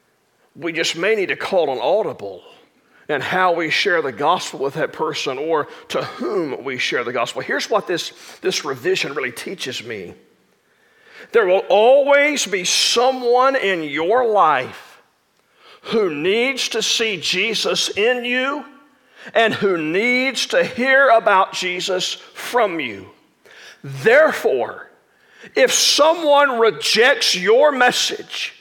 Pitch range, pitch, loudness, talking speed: 190-290 Hz, 245 Hz, -17 LUFS, 130 wpm